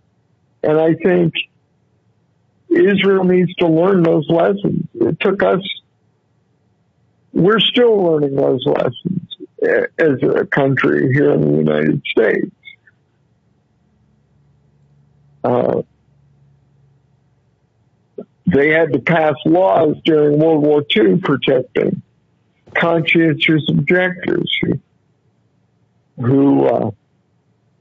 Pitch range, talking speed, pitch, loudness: 140-175 Hz, 90 wpm, 155 Hz, -15 LUFS